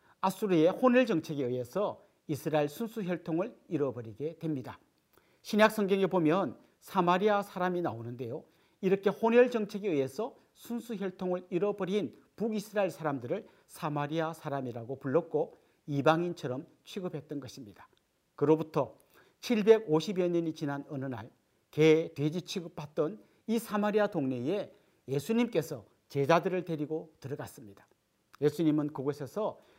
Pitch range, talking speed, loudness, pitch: 145-200 Hz, 310 characters per minute, -31 LUFS, 165 Hz